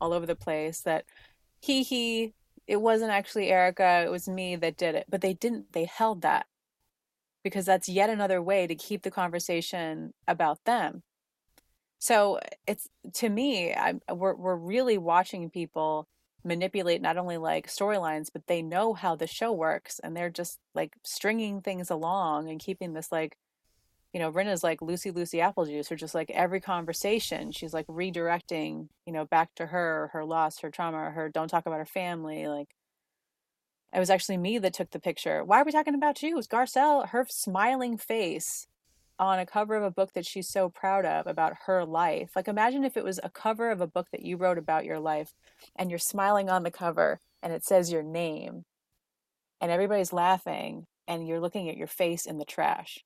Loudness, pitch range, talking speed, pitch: -29 LUFS, 165-200 Hz, 195 wpm, 180 Hz